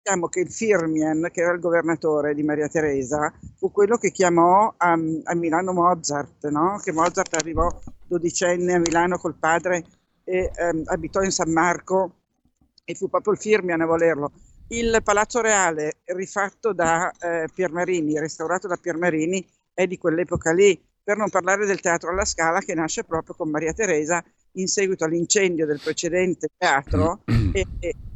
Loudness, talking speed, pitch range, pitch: -22 LUFS, 160 wpm, 160-185 Hz, 175 Hz